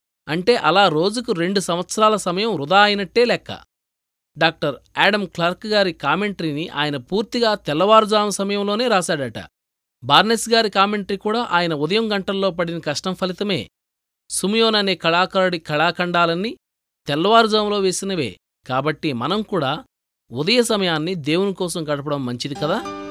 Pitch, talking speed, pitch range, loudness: 180 Hz, 115 wpm, 150-205 Hz, -19 LUFS